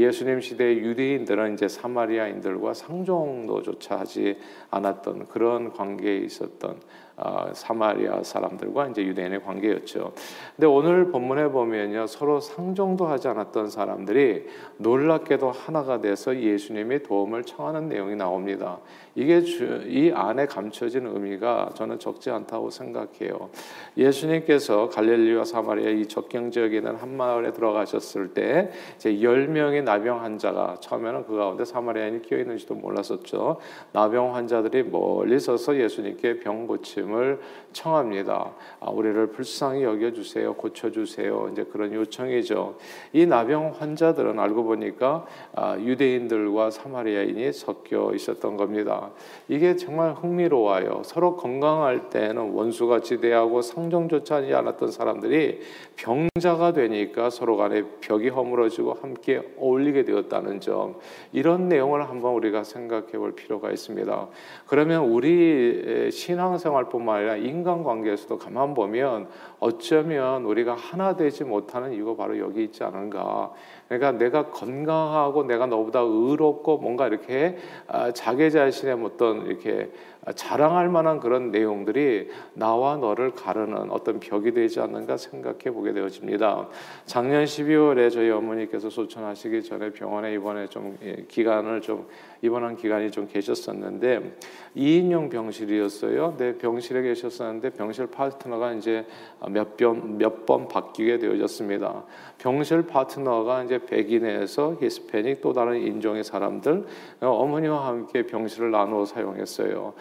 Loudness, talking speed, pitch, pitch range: -25 LUFS, 330 characters per minute, 125 Hz, 110-160 Hz